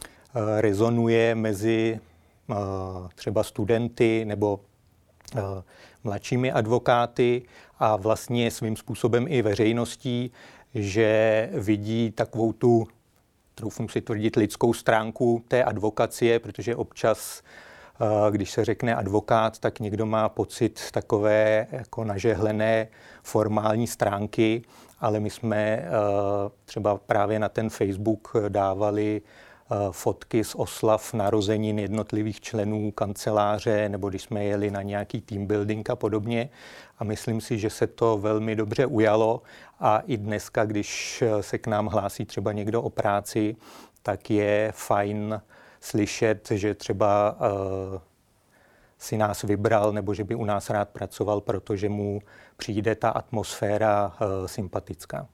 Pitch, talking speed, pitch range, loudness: 110 Hz, 125 wpm, 105-115 Hz, -26 LUFS